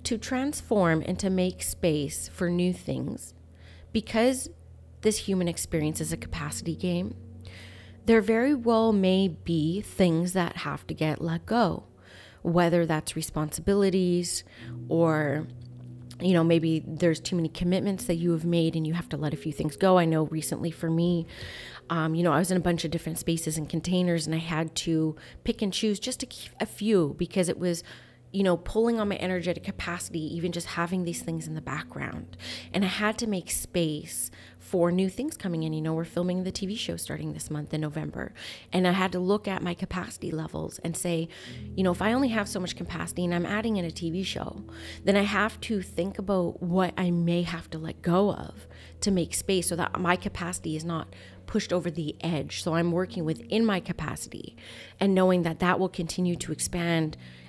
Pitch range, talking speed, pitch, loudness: 155-185 Hz, 200 wpm, 170 Hz, -28 LUFS